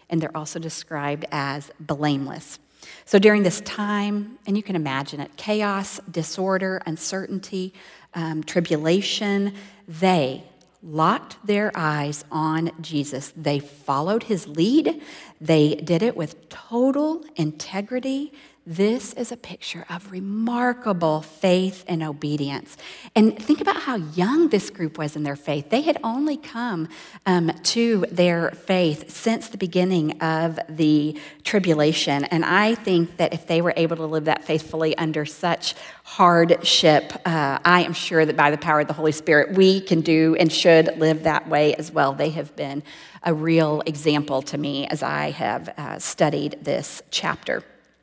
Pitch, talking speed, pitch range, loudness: 170 Hz, 150 wpm, 155-200 Hz, -22 LUFS